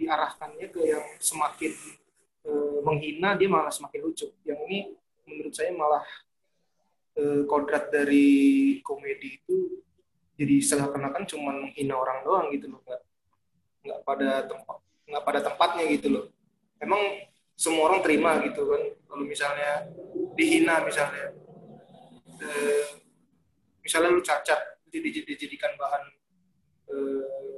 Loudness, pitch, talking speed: -27 LUFS, 165 Hz, 120 wpm